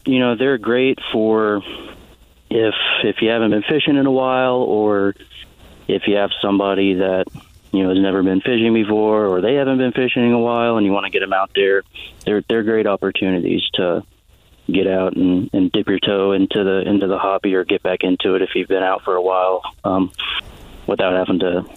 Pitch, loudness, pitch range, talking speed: 100 Hz, -17 LUFS, 95-115 Hz, 210 wpm